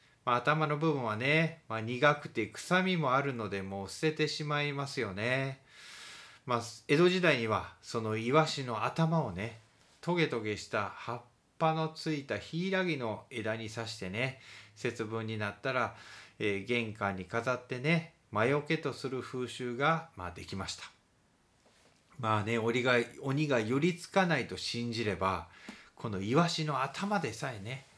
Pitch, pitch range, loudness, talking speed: 125 Hz, 110-155 Hz, -33 LUFS, 285 characters per minute